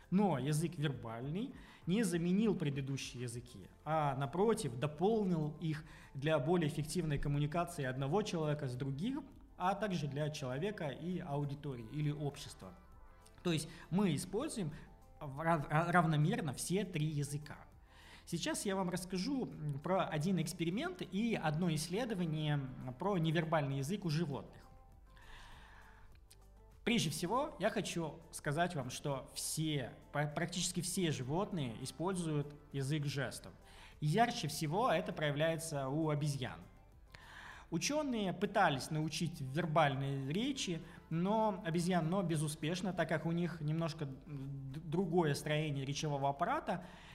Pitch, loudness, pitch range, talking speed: 155 Hz, -38 LUFS, 140-180 Hz, 110 wpm